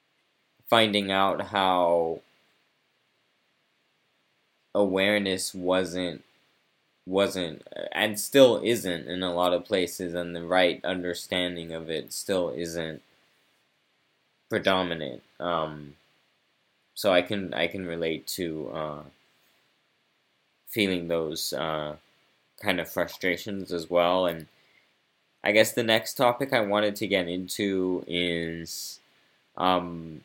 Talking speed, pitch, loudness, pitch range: 105 wpm, 90 Hz, -27 LUFS, 85-95 Hz